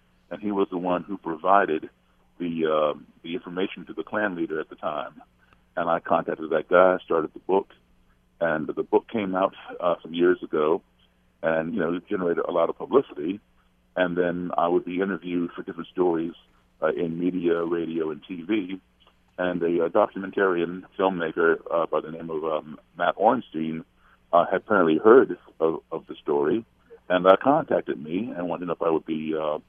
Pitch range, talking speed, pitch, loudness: 80-95 Hz, 185 wpm, 85 Hz, -25 LUFS